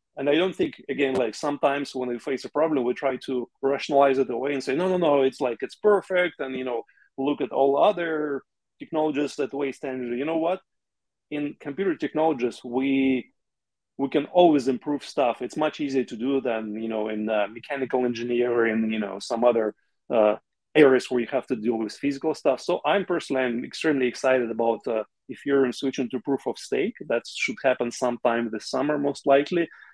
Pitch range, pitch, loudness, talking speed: 120-145 Hz, 135 Hz, -25 LUFS, 200 wpm